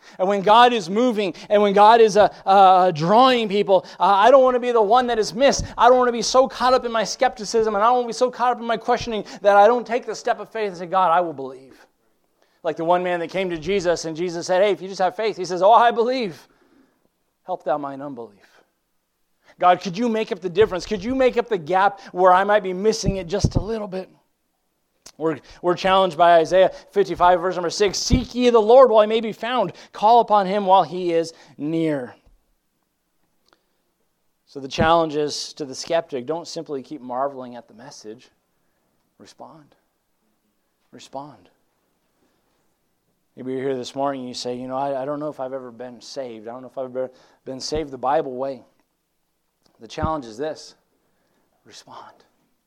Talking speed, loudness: 210 wpm, -19 LUFS